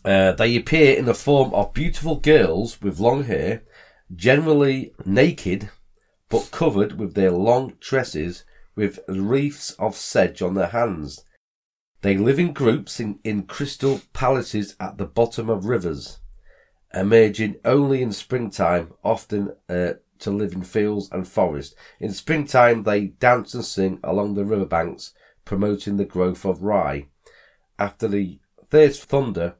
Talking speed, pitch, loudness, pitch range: 145 wpm, 105 Hz, -21 LUFS, 95-130 Hz